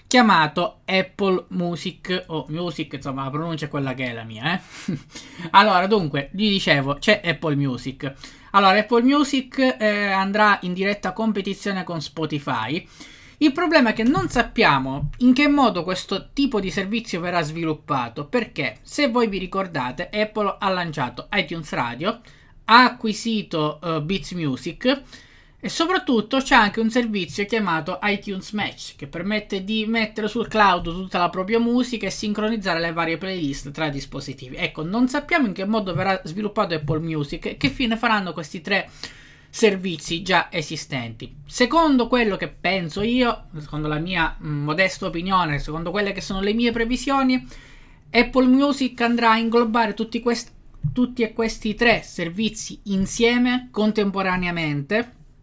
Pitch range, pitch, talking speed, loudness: 160-225 Hz, 195 Hz, 150 wpm, -21 LUFS